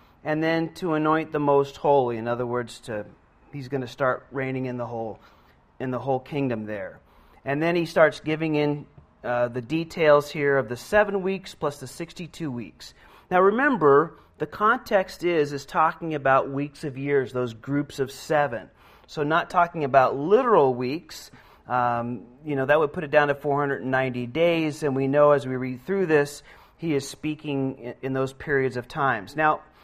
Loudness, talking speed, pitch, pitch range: -24 LUFS, 185 wpm, 140 Hz, 130-155 Hz